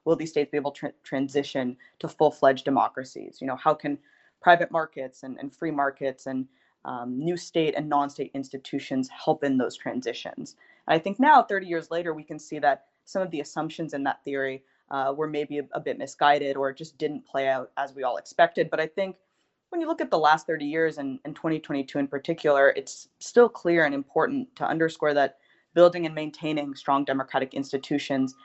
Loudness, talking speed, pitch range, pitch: -26 LUFS, 205 wpm, 135-160 Hz, 145 Hz